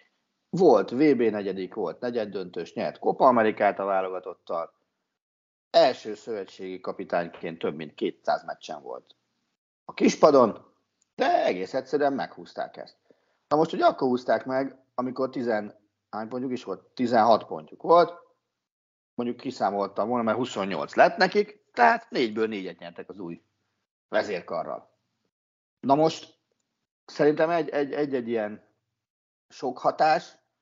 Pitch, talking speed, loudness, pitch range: 120 Hz, 120 wpm, -25 LUFS, 100-145 Hz